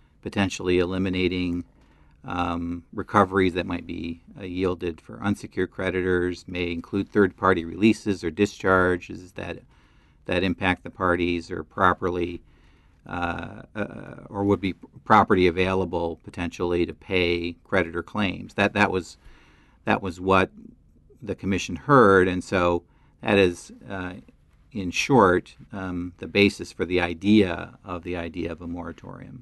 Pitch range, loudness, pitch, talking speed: 85-95 Hz, -24 LUFS, 90 Hz, 135 wpm